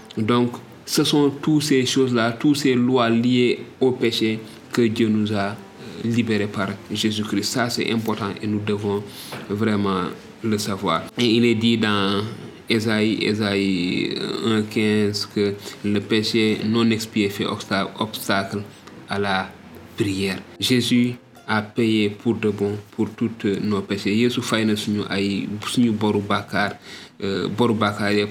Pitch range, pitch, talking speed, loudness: 100-115 Hz, 110 Hz, 120 wpm, -21 LUFS